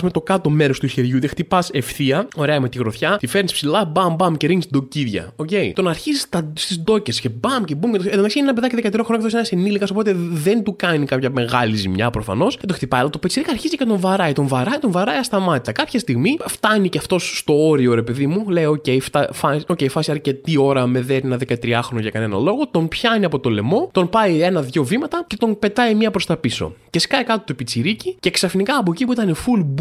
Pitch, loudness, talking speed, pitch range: 170 Hz, -18 LUFS, 245 wpm, 135-210 Hz